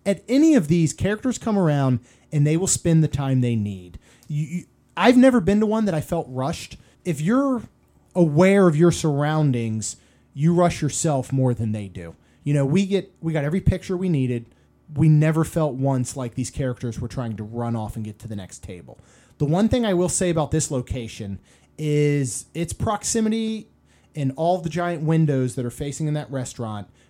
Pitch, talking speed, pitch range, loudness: 150 Hz, 200 wpm, 125-175 Hz, -22 LUFS